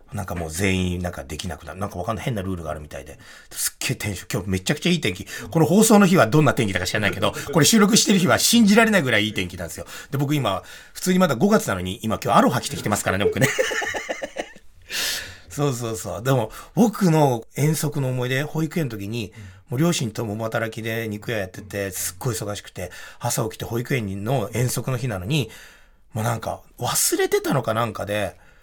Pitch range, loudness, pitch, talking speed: 100-150 Hz, -22 LUFS, 115 Hz, 440 characters per minute